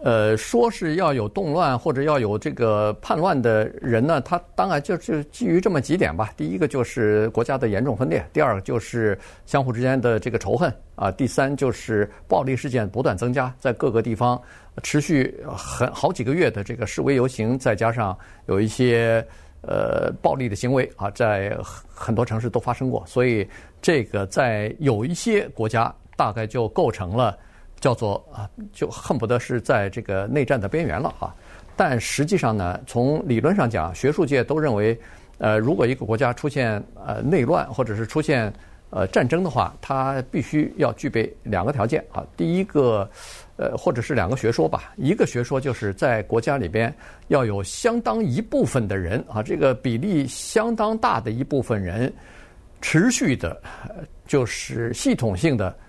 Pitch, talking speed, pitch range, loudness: 120 Hz, 265 characters per minute, 110-140 Hz, -22 LUFS